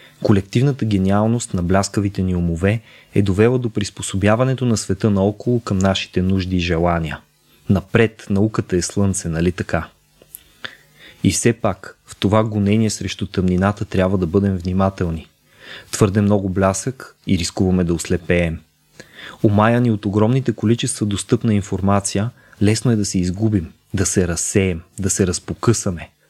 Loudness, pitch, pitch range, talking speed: -19 LUFS, 100 Hz, 90-110 Hz, 135 wpm